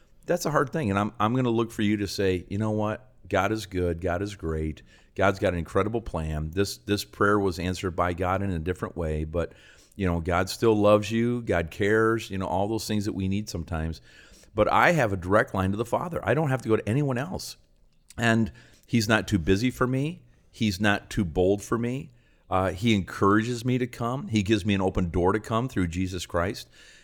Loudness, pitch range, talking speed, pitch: -26 LUFS, 90-110 Hz, 230 wpm, 100 Hz